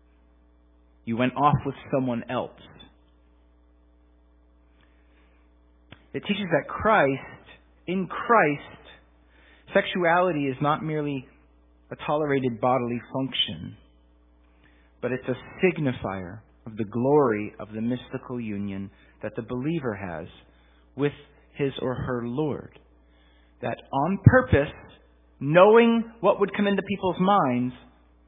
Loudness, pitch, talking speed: -25 LUFS, 120 Hz, 105 wpm